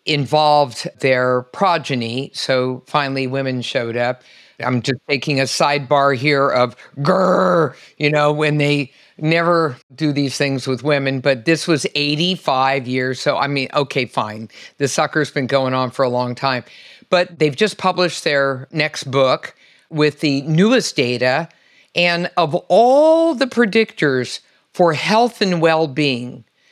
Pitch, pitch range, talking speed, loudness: 145 Hz, 130-165 Hz, 145 wpm, -17 LUFS